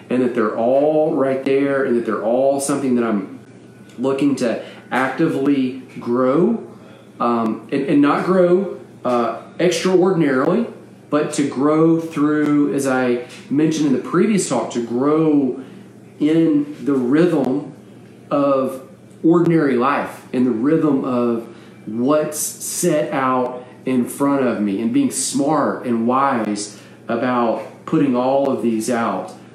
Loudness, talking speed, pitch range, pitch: -18 LUFS, 130 wpm, 120-155 Hz, 135 Hz